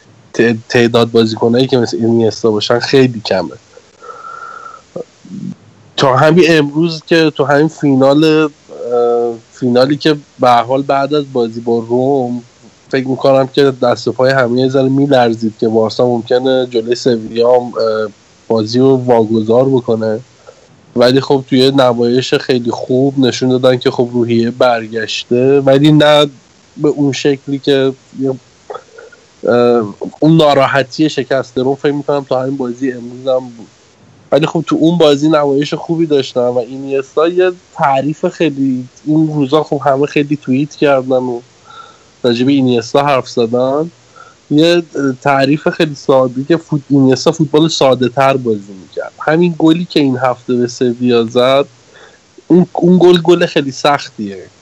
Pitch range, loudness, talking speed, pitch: 120-150 Hz, -12 LUFS, 135 wpm, 135 Hz